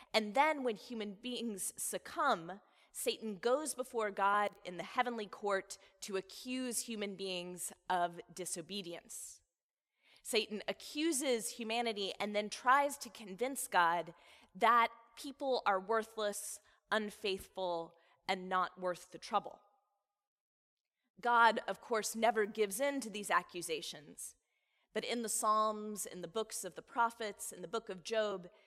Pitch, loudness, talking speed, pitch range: 215 Hz, -37 LUFS, 130 wpm, 195-235 Hz